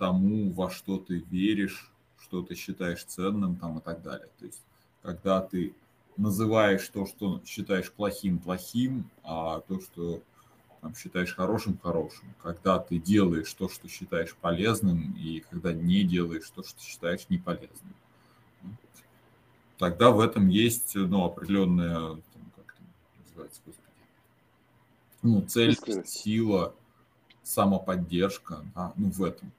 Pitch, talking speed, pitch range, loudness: 95 Hz, 130 wpm, 85-105 Hz, -29 LUFS